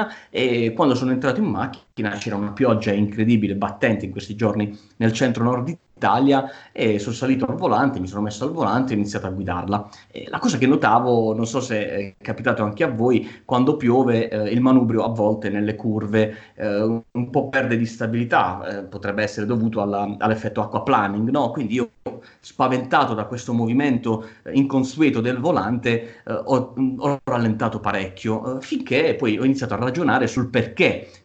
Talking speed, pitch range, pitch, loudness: 180 wpm, 105-130 Hz, 115 Hz, -21 LUFS